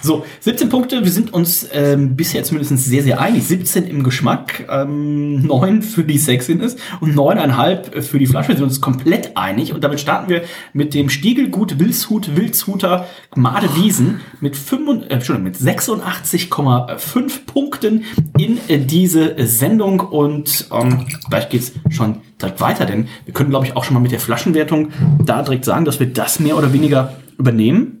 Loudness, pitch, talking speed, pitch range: -16 LUFS, 150 Hz, 170 wpm, 135-185 Hz